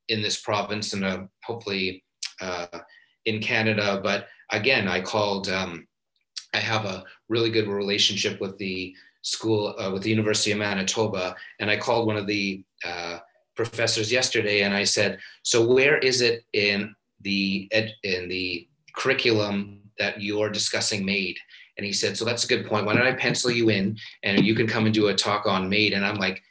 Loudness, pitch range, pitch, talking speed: -24 LUFS, 95-110 Hz, 105 Hz, 190 wpm